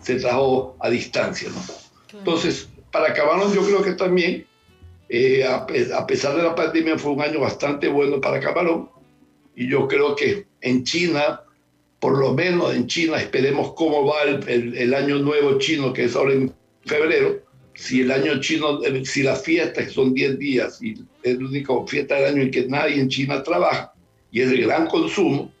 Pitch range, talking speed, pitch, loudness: 130-185 Hz, 190 wpm, 145 Hz, -20 LUFS